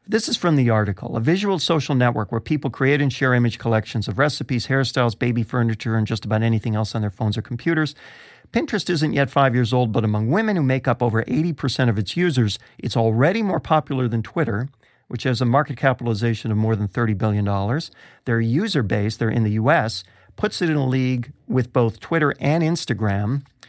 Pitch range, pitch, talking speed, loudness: 115-145 Hz, 125 Hz, 205 wpm, -21 LUFS